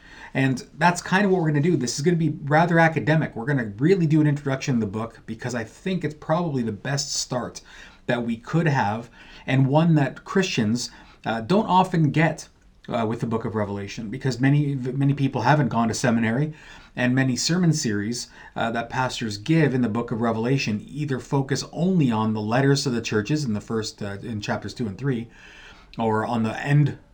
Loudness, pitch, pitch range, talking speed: -23 LUFS, 130 Hz, 115-150 Hz, 210 wpm